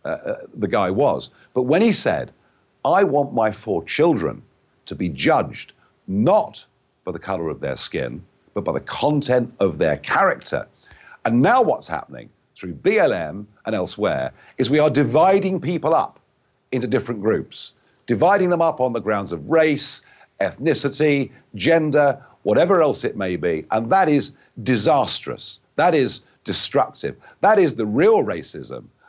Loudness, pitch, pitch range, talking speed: -20 LUFS, 145 Hz, 125-165 Hz, 155 wpm